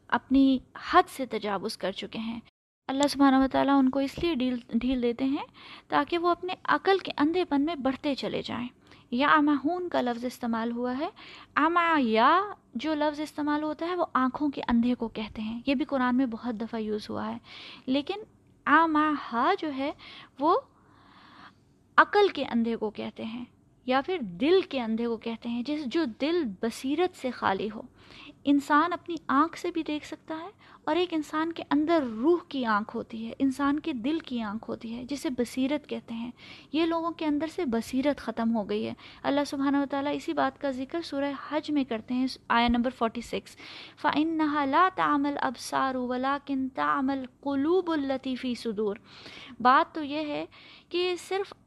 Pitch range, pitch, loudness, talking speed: 240-315 Hz, 280 Hz, -28 LUFS, 180 wpm